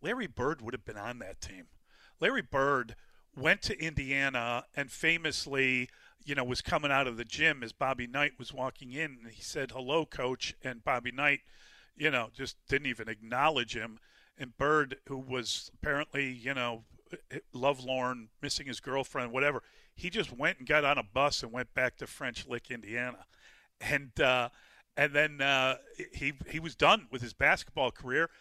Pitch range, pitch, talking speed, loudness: 120-140 Hz, 130 Hz, 175 wpm, -32 LUFS